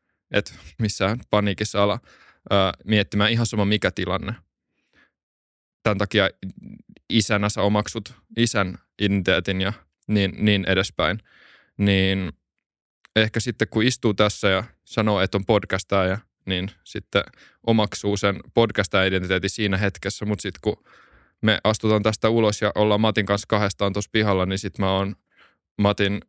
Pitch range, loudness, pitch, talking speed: 95-110 Hz, -22 LUFS, 100 Hz, 135 wpm